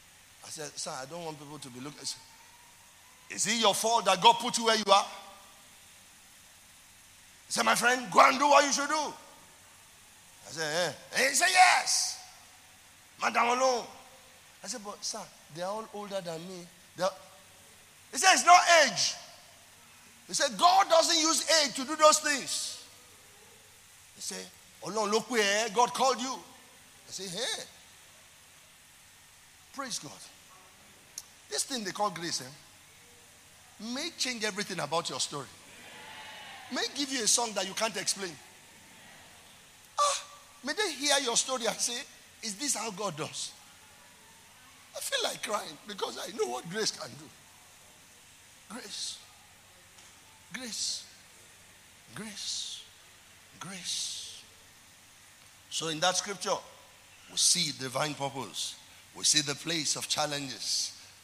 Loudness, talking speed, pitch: -28 LUFS, 140 wpm, 195 Hz